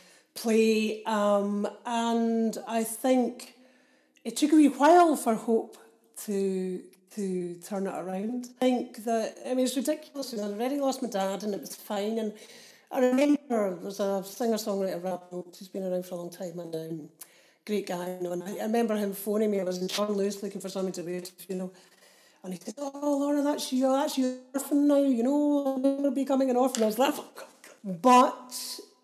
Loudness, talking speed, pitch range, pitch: -28 LUFS, 200 wpm, 195-260 Hz, 220 Hz